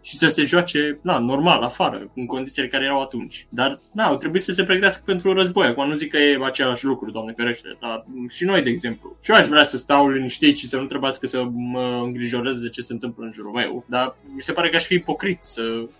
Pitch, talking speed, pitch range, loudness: 135 Hz, 245 wpm, 125-155 Hz, -20 LUFS